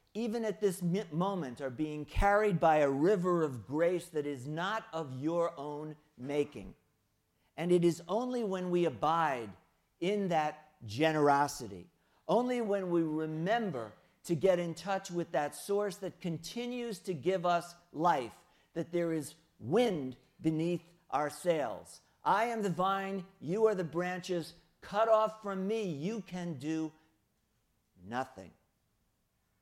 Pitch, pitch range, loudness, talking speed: 170 Hz, 155-195 Hz, -33 LUFS, 140 wpm